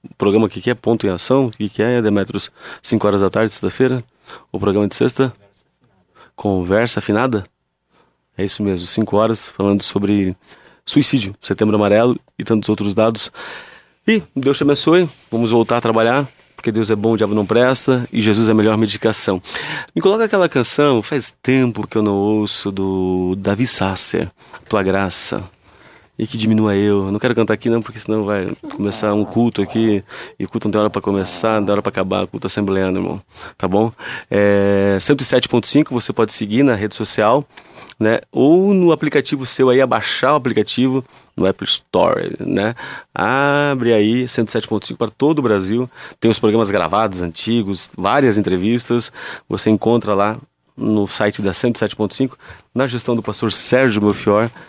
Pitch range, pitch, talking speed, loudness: 100-125 Hz, 110 Hz, 170 wpm, -16 LUFS